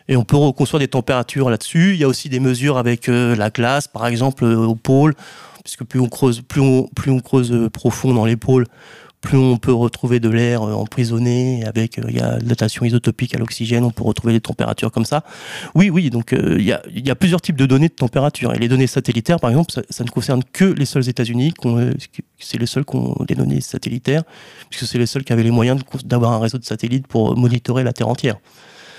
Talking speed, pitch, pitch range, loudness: 240 wpm, 125 Hz, 120-135 Hz, -17 LUFS